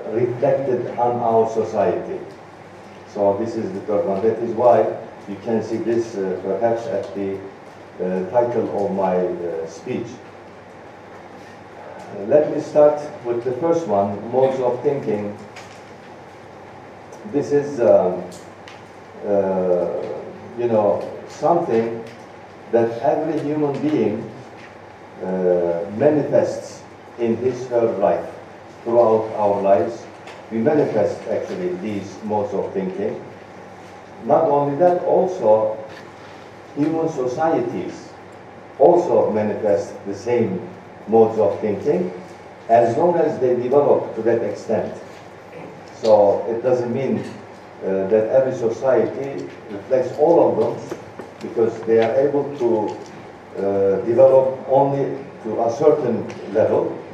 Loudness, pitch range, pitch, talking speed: -19 LUFS, 100-135 Hz, 115 Hz, 115 wpm